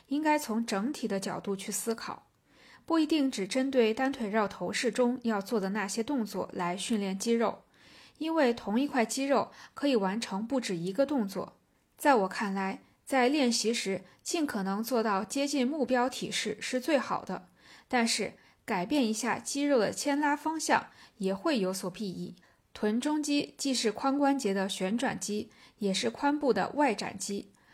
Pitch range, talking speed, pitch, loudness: 200-275 Hz, 245 characters per minute, 230 Hz, -30 LUFS